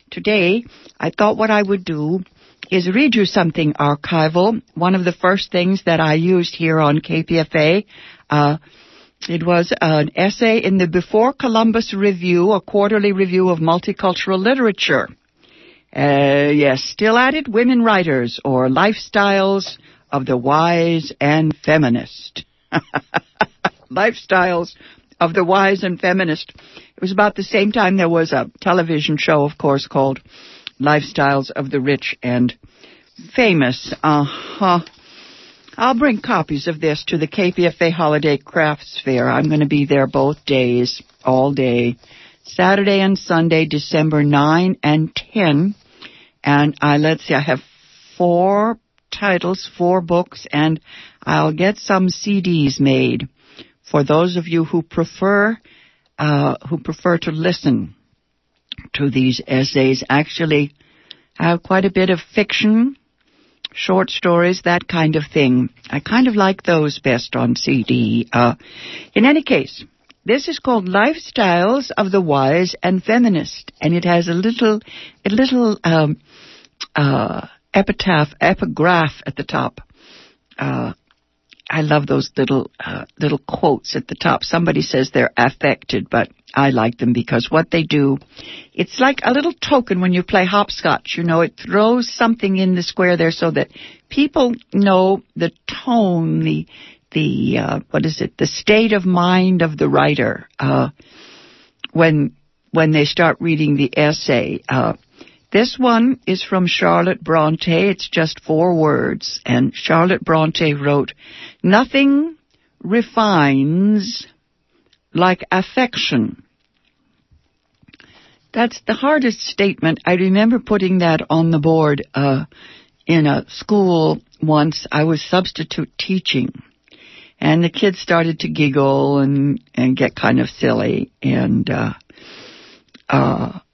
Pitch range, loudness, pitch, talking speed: 150-200 Hz, -16 LUFS, 170 Hz, 140 wpm